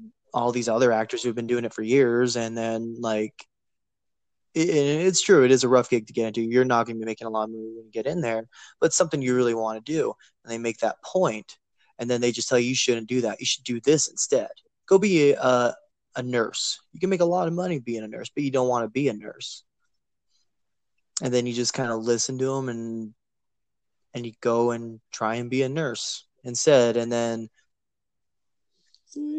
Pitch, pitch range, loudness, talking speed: 120 Hz, 115-130 Hz, -24 LUFS, 230 wpm